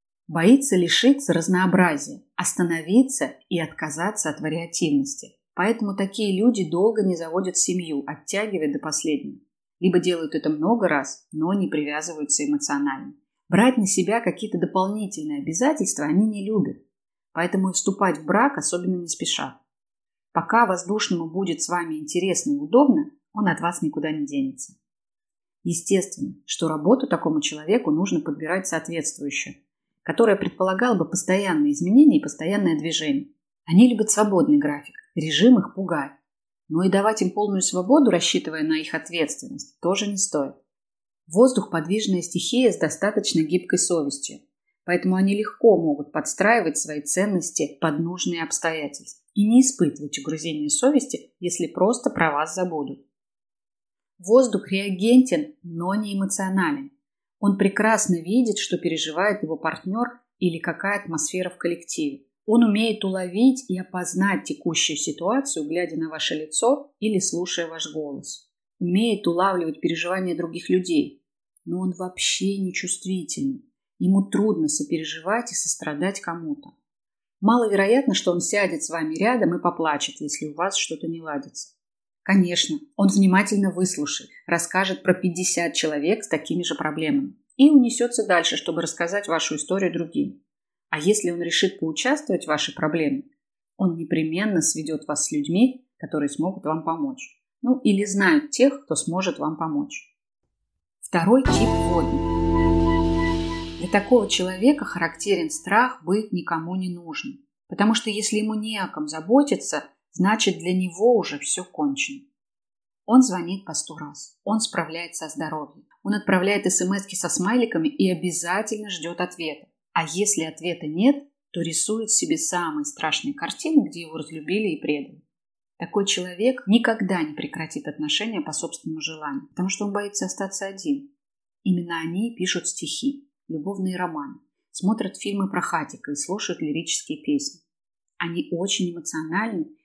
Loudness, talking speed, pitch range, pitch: -23 LUFS, 140 wpm, 165-230 Hz, 185 Hz